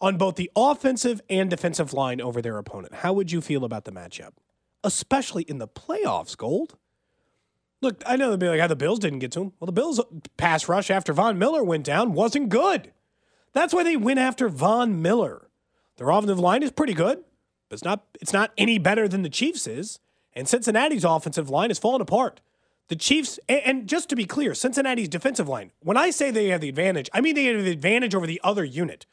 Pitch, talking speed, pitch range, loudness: 195 Hz, 215 wpm, 165-245 Hz, -24 LUFS